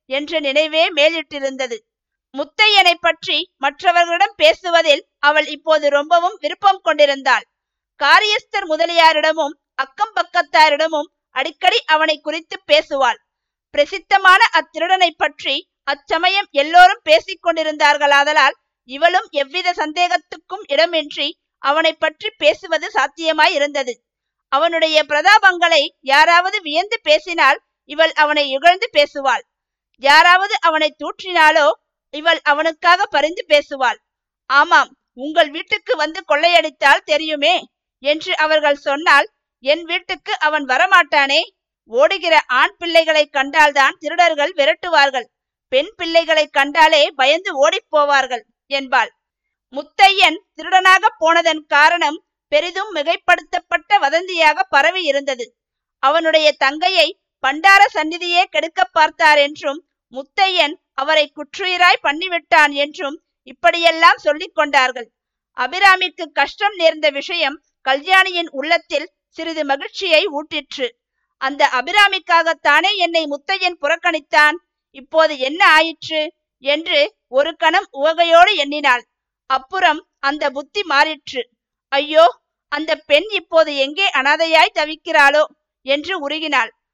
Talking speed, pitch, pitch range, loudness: 95 wpm, 315 Hz, 290-350 Hz, -15 LUFS